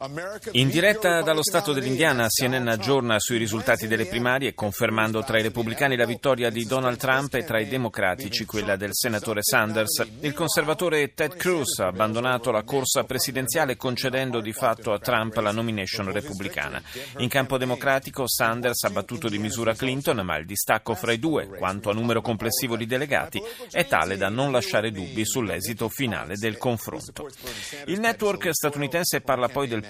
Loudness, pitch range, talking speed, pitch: -24 LUFS, 110-135 Hz, 165 wpm, 120 Hz